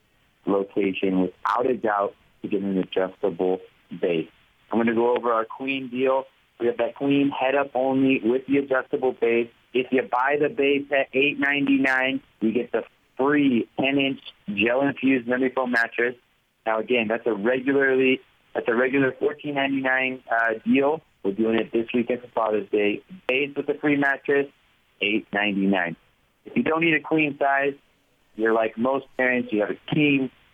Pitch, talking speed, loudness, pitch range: 130 Hz, 170 wpm, -23 LUFS, 115-140 Hz